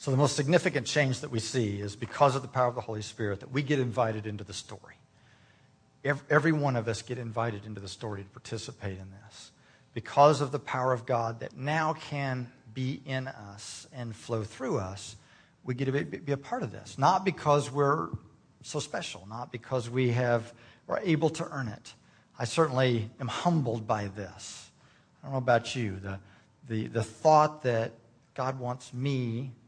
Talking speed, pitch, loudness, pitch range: 190 wpm, 125 Hz, -30 LUFS, 110-140 Hz